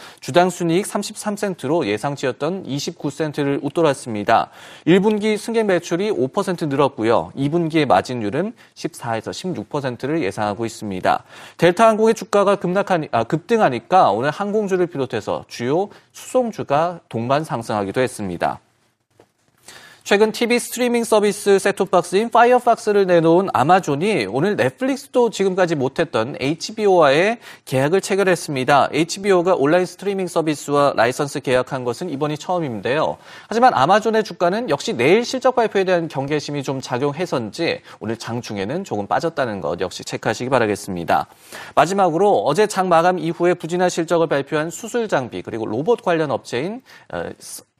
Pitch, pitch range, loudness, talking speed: 170 Hz, 140-200 Hz, -19 LUFS, 345 characters per minute